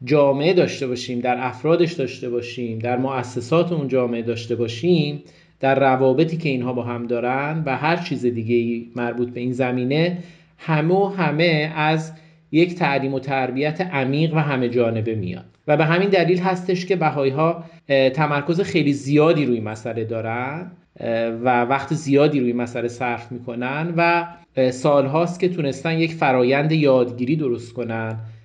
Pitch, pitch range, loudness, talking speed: 135 Hz, 120-160 Hz, -20 LUFS, 150 wpm